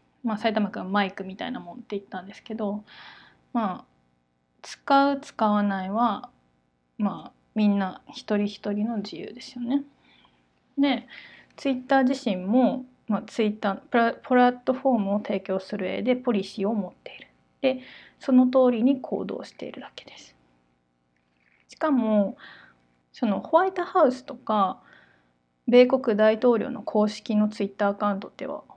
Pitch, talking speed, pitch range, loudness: 215 Hz, 300 characters per minute, 195-255 Hz, -25 LUFS